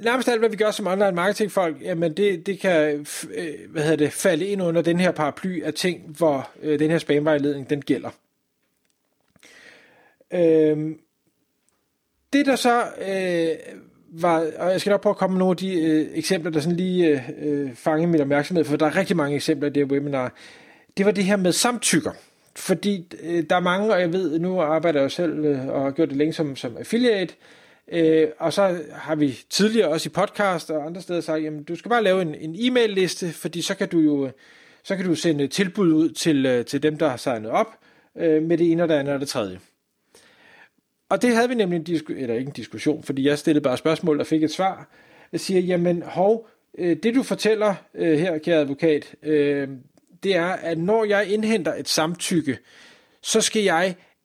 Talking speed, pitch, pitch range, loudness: 190 wpm, 165 Hz, 150-190 Hz, -22 LUFS